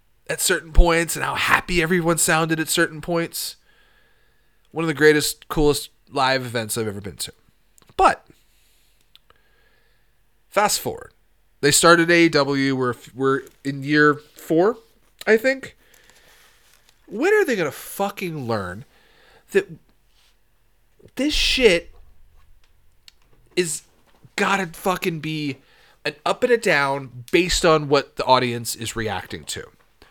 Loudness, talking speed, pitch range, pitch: -20 LUFS, 120 wpm, 130-185 Hz, 155 Hz